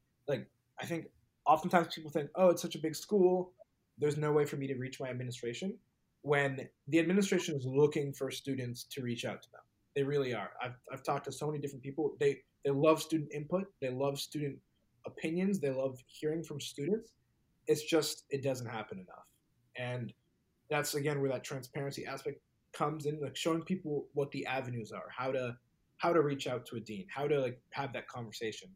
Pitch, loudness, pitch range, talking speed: 145 Hz, -35 LUFS, 130-160 Hz, 200 wpm